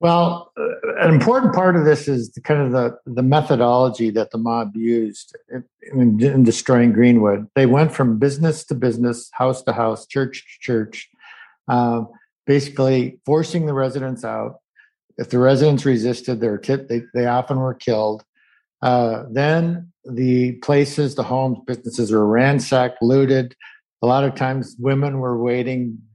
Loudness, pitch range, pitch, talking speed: -18 LUFS, 120-140 Hz, 125 Hz, 155 wpm